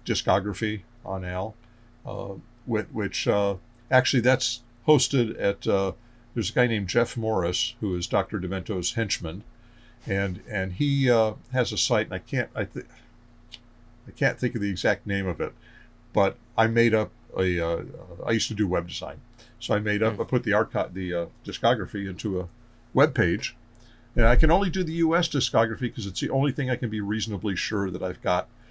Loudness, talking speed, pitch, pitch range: -26 LUFS, 190 wpm, 115 Hz, 100-120 Hz